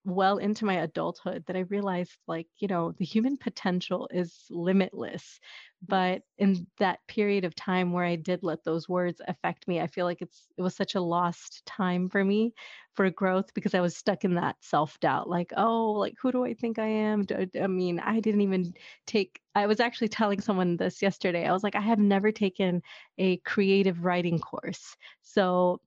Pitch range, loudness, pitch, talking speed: 180-205 Hz, -28 LUFS, 185 Hz, 195 wpm